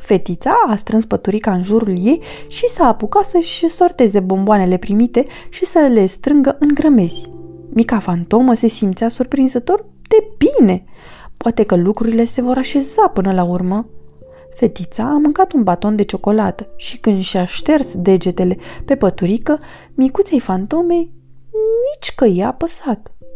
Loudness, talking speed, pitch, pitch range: -15 LUFS, 145 wpm, 230 Hz, 190-295 Hz